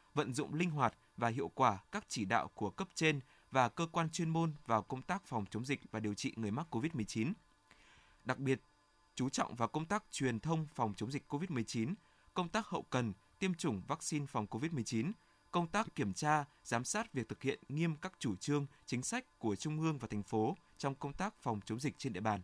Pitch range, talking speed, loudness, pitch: 115-160 Hz, 220 wpm, -39 LUFS, 140 Hz